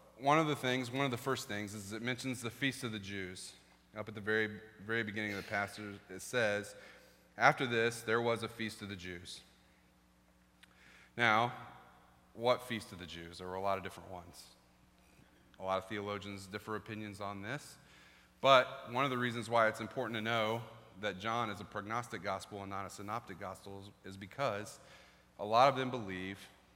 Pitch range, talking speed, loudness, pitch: 95-115 Hz, 195 wpm, -36 LUFS, 105 Hz